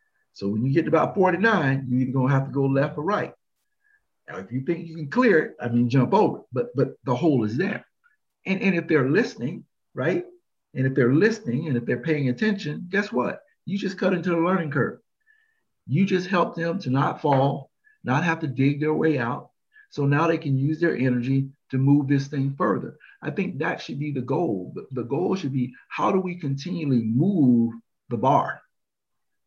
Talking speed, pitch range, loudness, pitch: 210 wpm, 135-185 Hz, -24 LUFS, 150 Hz